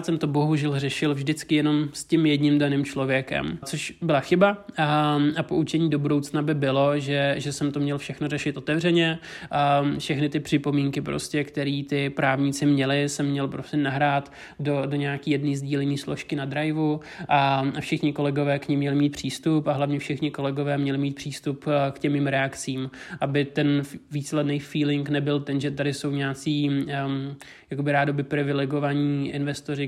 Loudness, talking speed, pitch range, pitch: -25 LUFS, 165 wpm, 140-150 Hz, 145 Hz